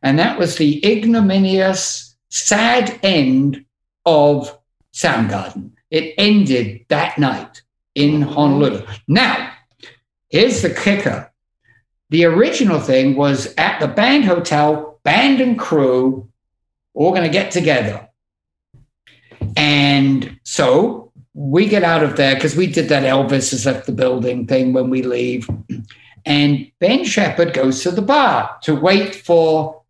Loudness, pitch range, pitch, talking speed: -15 LUFS, 130-180 Hz, 150 Hz, 130 wpm